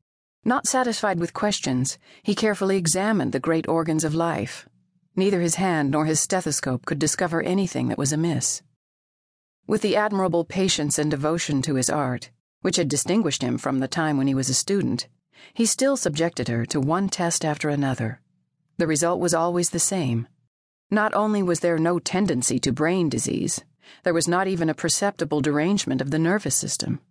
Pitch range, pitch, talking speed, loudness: 145-190 Hz, 165 Hz, 175 wpm, -23 LUFS